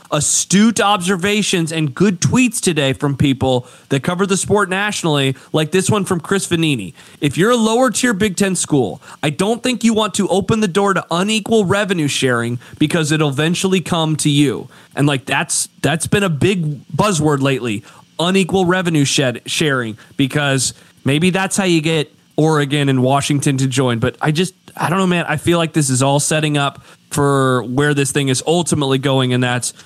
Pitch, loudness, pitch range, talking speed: 155 Hz, -16 LUFS, 140-190 Hz, 185 wpm